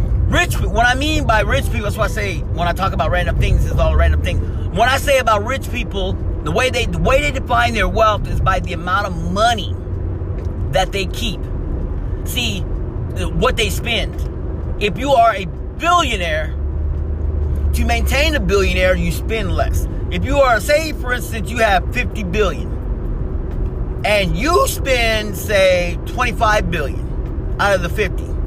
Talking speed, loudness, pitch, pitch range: 175 wpm, -18 LUFS, 90 Hz, 75-95 Hz